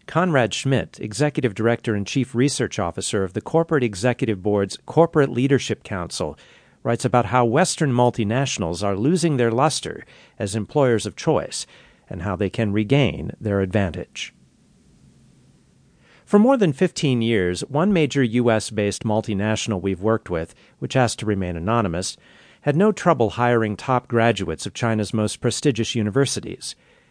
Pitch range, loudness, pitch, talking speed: 105-135 Hz, -21 LUFS, 115 Hz, 145 wpm